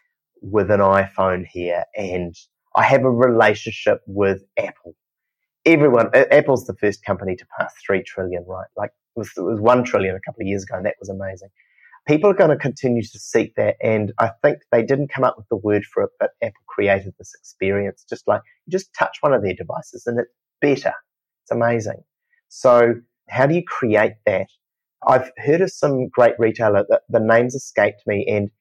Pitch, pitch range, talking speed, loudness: 115 Hz, 100-125 Hz, 200 wpm, -19 LUFS